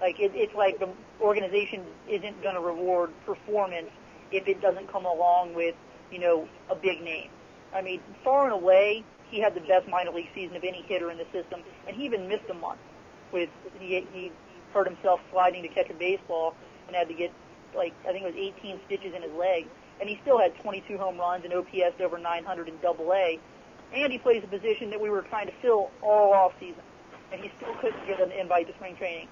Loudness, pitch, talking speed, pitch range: -28 LUFS, 185 Hz, 220 wpm, 180-205 Hz